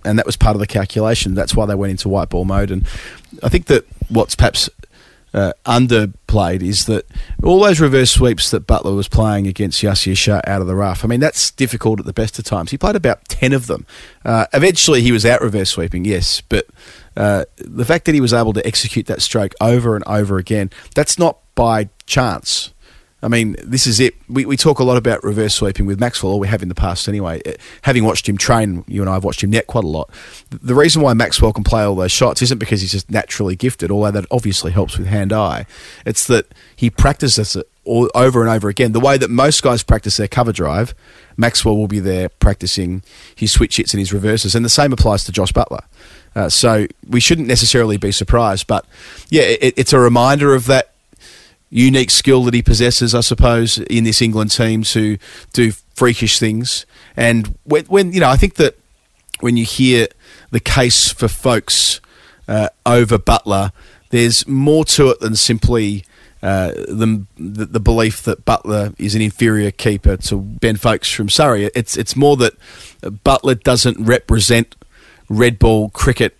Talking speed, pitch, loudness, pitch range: 200 wpm, 110 Hz, -14 LUFS, 100-120 Hz